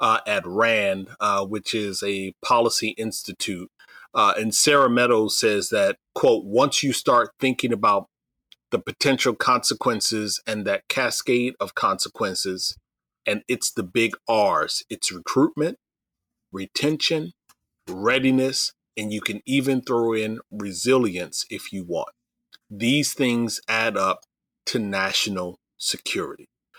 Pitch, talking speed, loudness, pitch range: 110 Hz, 125 wpm, -22 LUFS, 95-125 Hz